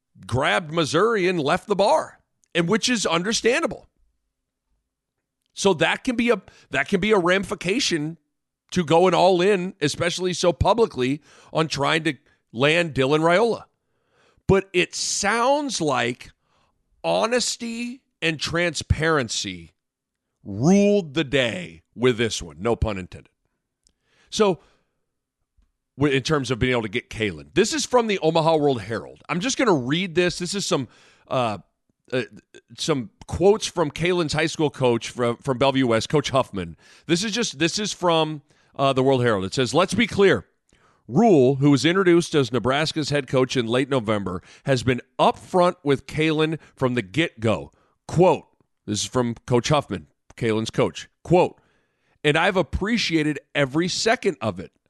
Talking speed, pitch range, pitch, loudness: 155 wpm, 125-180 Hz, 155 Hz, -22 LUFS